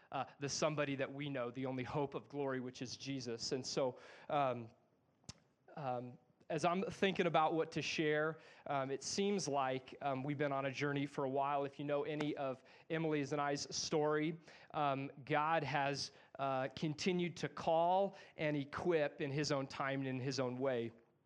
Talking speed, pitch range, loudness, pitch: 185 wpm, 135-155 Hz, -39 LUFS, 145 Hz